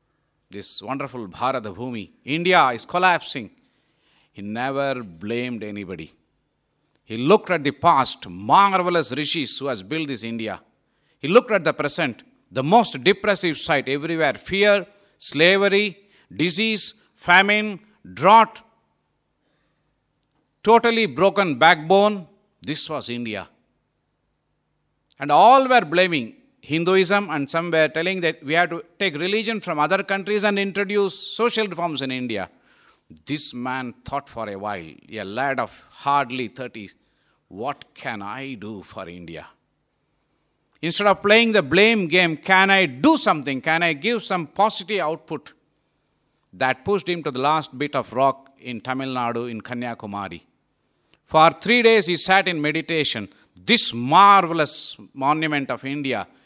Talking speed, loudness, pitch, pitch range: 135 wpm, -20 LUFS, 155 Hz, 130-195 Hz